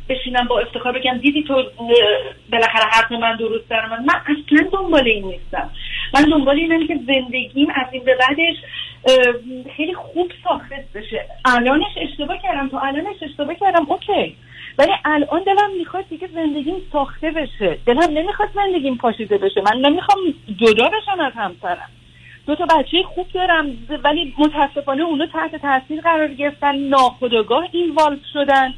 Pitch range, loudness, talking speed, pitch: 255-330 Hz, -17 LUFS, 150 wpm, 290 Hz